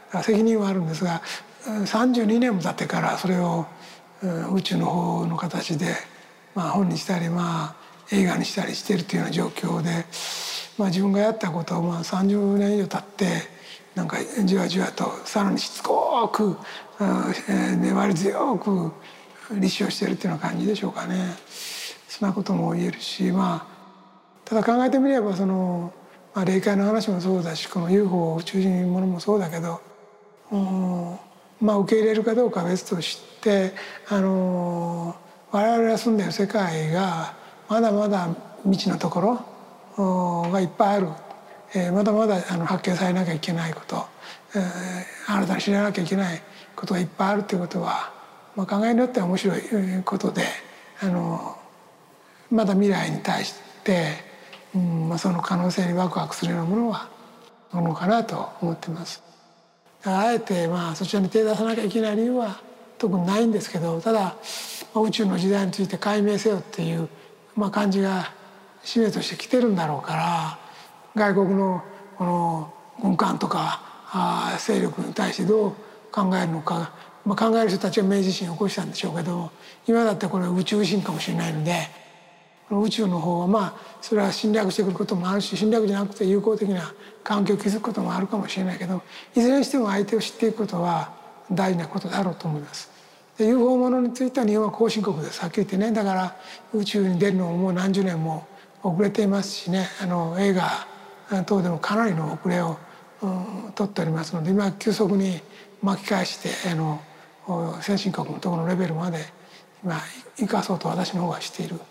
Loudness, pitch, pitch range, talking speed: -24 LUFS, 195 Hz, 175-210 Hz, 345 characters per minute